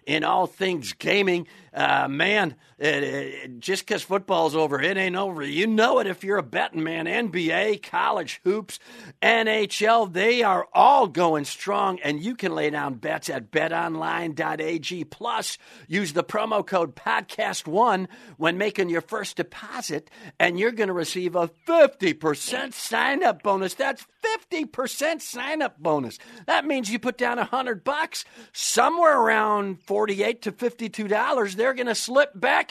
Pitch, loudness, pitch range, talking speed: 200 Hz, -24 LUFS, 170-230 Hz, 150 wpm